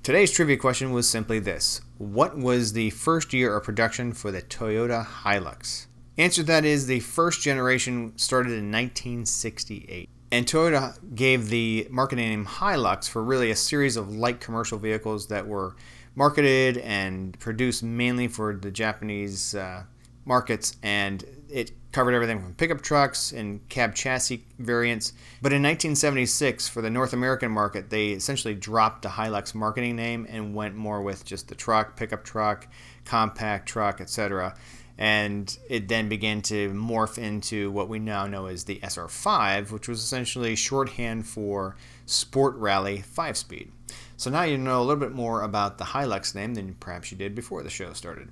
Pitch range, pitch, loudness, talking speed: 105-125 Hz, 115 Hz, -26 LUFS, 165 wpm